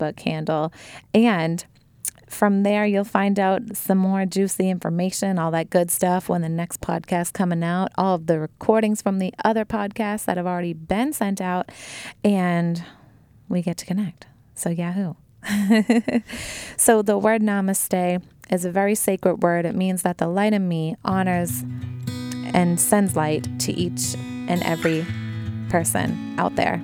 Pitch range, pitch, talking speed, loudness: 165-200 Hz, 180 Hz, 155 wpm, -22 LUFS